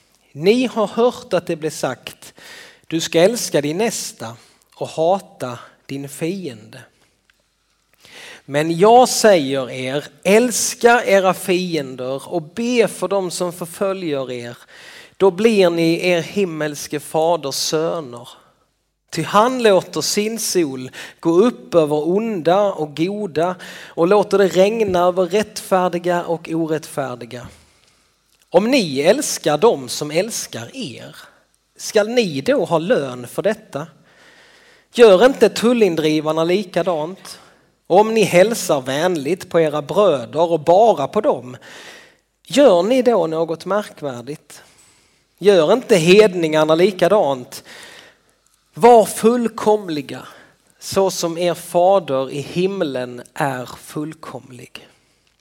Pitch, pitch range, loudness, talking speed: 175 Hz, 155-210 Hz, -17 LUFS, 115 wpm